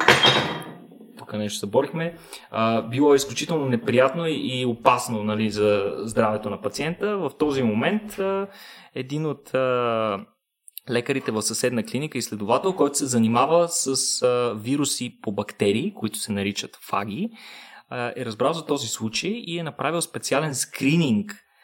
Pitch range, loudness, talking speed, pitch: 115-160 Hz, -23 LUFS, 125 wpm, 130 Hz